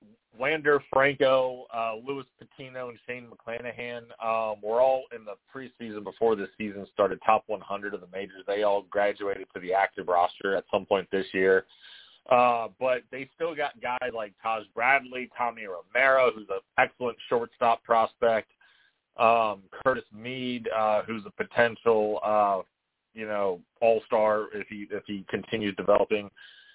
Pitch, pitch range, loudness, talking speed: 115 Hz, 105-125 Hz, -27 LUFS, 160 wpm